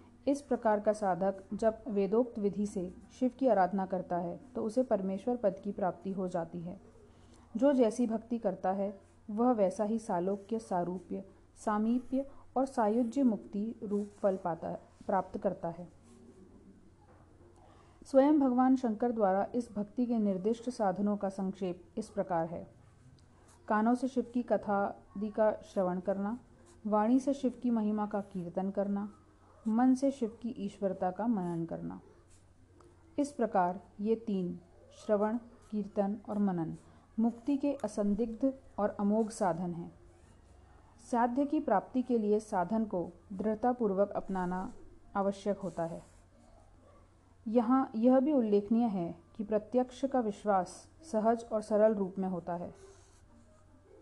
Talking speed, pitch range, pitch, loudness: 135 wpm, 180-230 Hz, 205 Hz, -33 LUFS